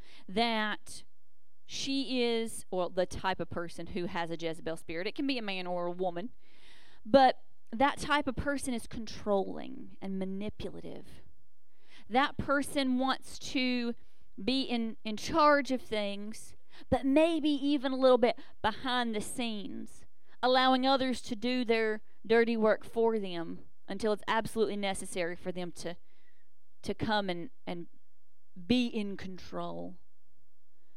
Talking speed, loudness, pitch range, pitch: 140 wpm, -32 LUFS, 185-255 Hz, 220 Hz